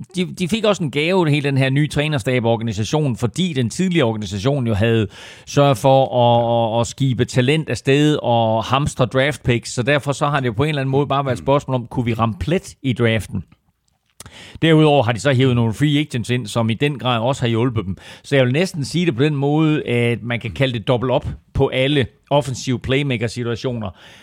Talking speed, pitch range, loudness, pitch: 215 wpm, 120-145 Hz, -18 LUFS, 130 Hz